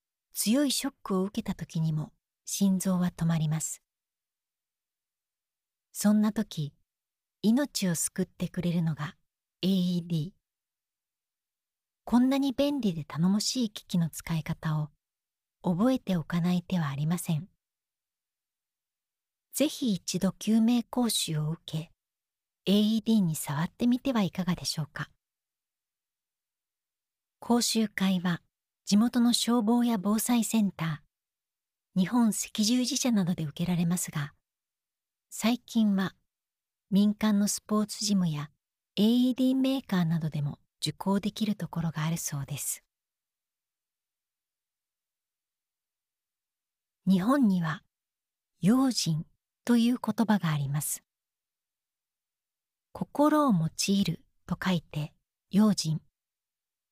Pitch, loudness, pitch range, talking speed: 190 Hz, -28 LUFS, 165-225 Hz, 210 characters per minute